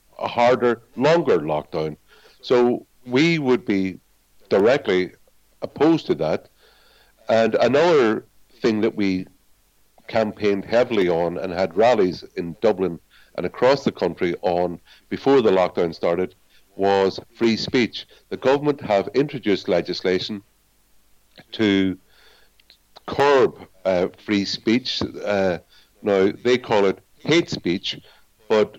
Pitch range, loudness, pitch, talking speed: 95-120 Hz, -21 LUFS, 100 Hz, 115 wpm